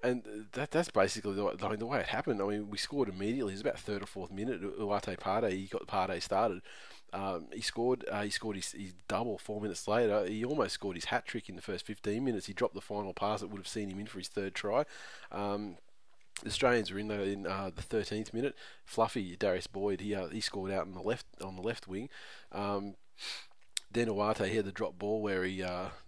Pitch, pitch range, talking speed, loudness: 100 Hz, 95-105 Hz, 235 wpm, -36 LUFS